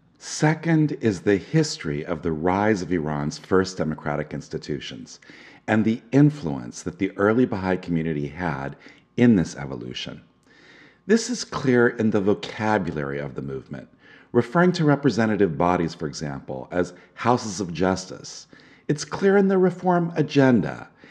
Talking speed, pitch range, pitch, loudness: 140 wpm, 85-140 Hz, 105 Hz, -23 LUFS